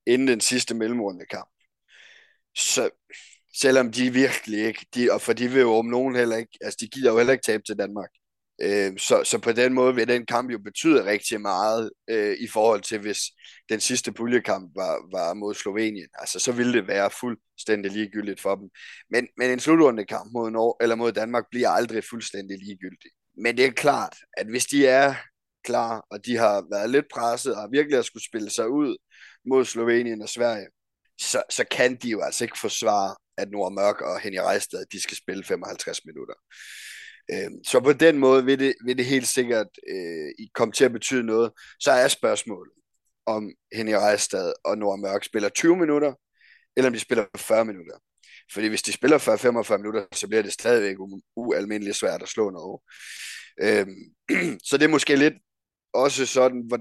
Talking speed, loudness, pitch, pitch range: 190 wpm, -23 LUFS, 125 Hz, 110-145 Hz